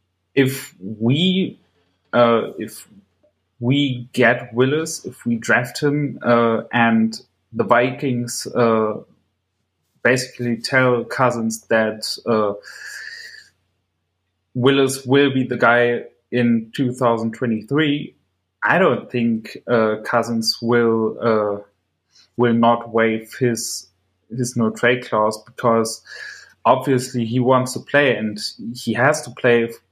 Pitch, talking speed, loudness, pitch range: 120 Hz, 110 wpm, -19 LUFS, 110-125 Hz